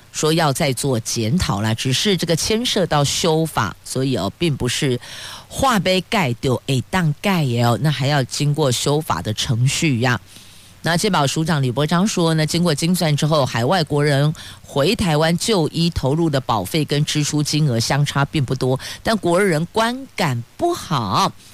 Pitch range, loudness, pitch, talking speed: 130-170 Hz, -19 LUFS, 150 Hz, 250 characters per minute